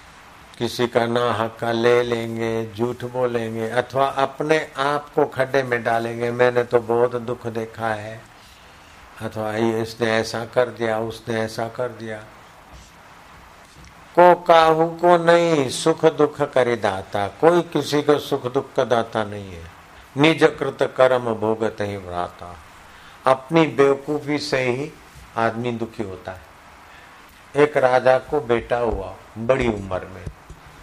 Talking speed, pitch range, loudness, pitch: 130 wpm, 110-135 Hz, -20 LUFS, 120 Hz